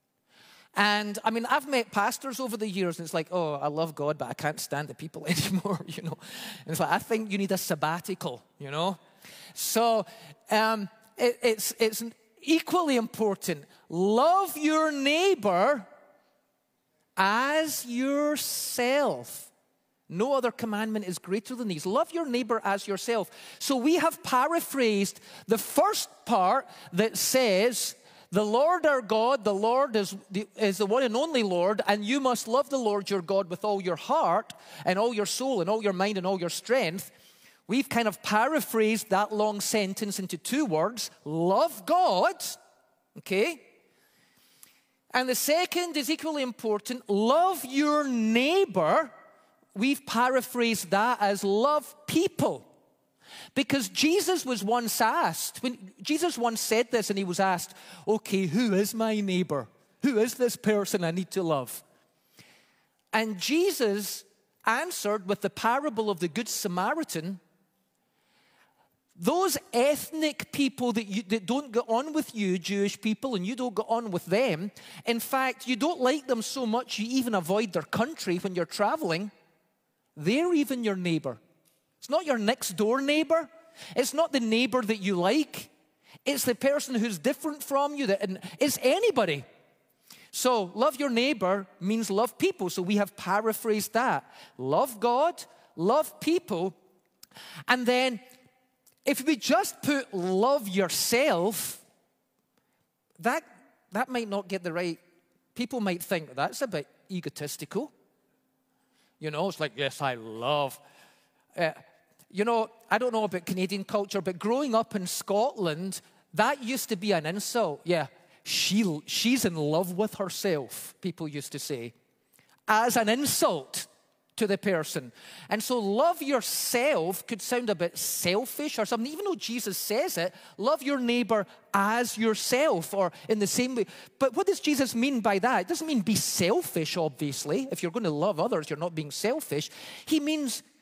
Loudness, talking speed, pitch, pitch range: -28 LUFS, 155 wpm, 220 Hz, 185-260 Hz